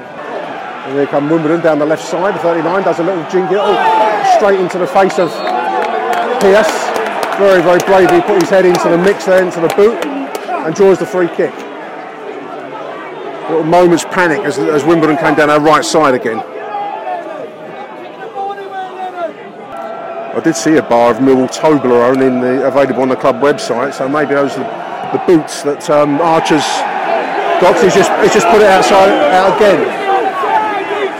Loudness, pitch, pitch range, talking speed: -11 LUFS, 170 Hz, 150-210 Hz, 160 wpm